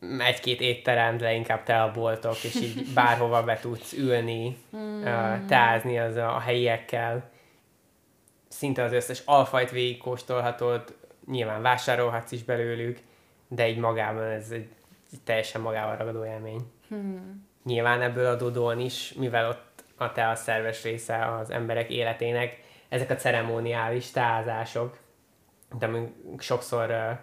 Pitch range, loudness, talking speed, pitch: 115-125 Hz, -27 LUFS, 125 wpm, 120 Hz